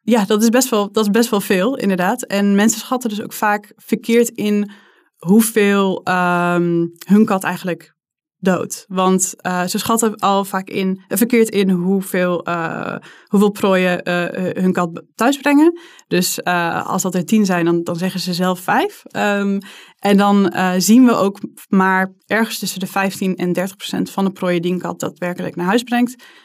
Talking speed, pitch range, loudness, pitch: 185 wpm, 180-220 Hz, -17 LUFS, 195 Hz